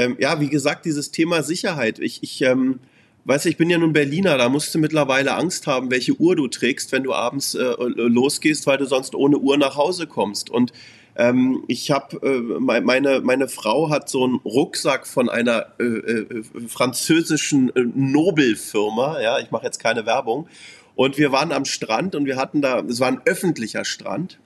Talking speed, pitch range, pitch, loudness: 190 wpm, 125-155 Hz, 135 Hz, -20 LUFS